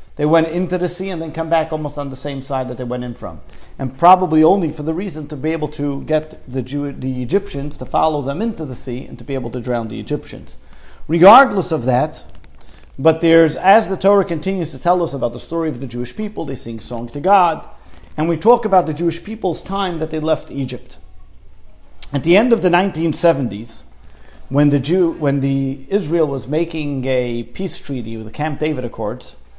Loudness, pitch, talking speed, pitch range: -18 LUFS, 145 Hz, 215 wpm, 125-165 Hz